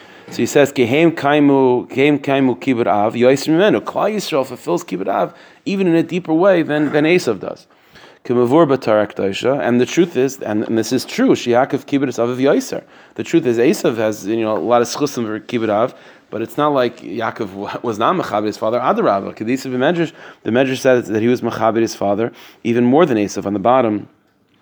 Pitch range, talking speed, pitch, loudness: 110-145 Hz, 180 wpm, 125 Hz, -16 LUFS